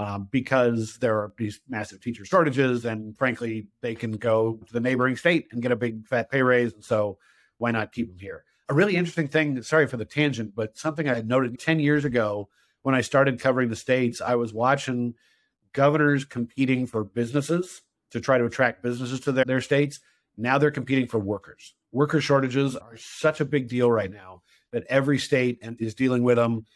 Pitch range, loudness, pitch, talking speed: 115-140 Hz, -25 LUFS, 125 Hz, 200 wpm